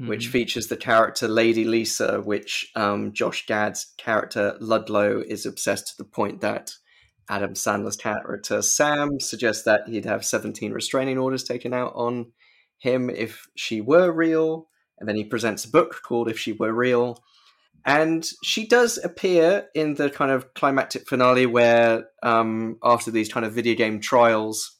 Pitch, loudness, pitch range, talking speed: 120 Hz, -22 LUFS, 110-140 Hz, 160 wpm